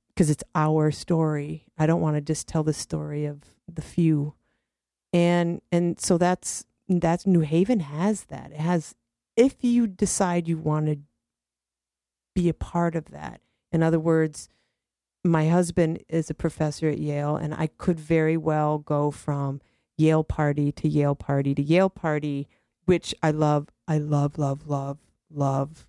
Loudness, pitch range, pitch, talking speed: -25 LUFS, 145-170 Hz, 155 Hz, 160 wpm